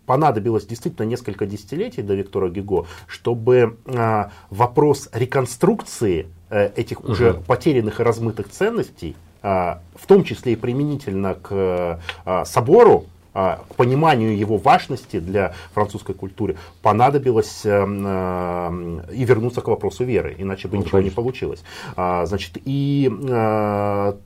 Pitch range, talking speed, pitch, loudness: 95-120 Hz, 105 wpm, 105 Hz, -20 LUFS